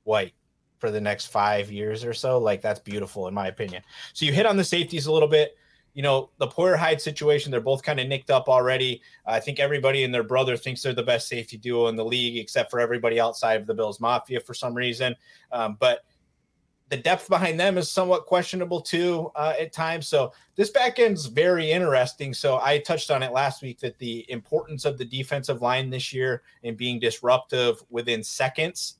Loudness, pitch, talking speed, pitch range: -24 LUFS, 130 Hz, 215 wpm, 120-155 Hz